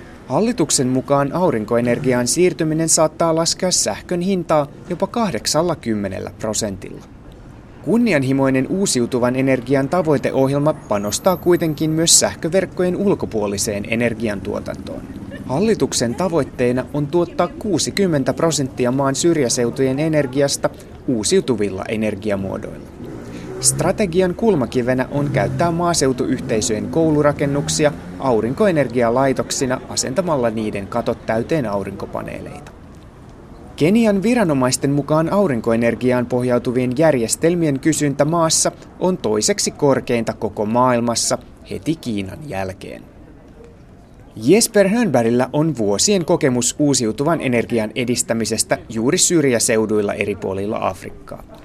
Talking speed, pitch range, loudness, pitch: 85 wpm, 115-165 Hz, -18 LUFS, 135 Hz